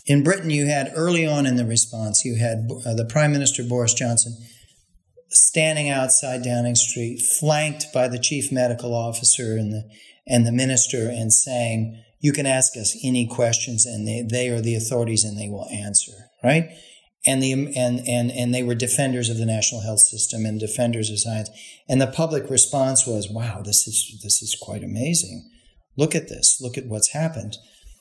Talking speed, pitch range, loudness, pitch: 185 wpm, 110-135 Hz, -20 LUFS, 120 Hz